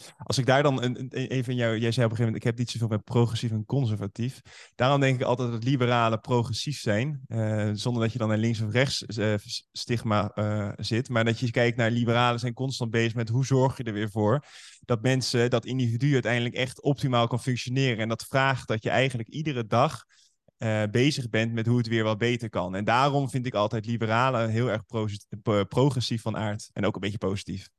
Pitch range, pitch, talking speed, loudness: 110-130 Hz, 120 Hz, 220 wpm, -26 LUFS